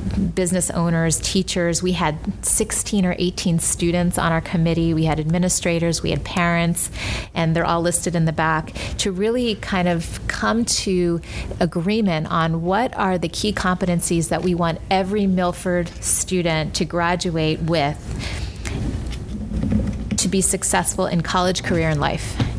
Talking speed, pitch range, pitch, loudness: 145 wpm, 165-185 Hz, 175 Hz, -20 LUFS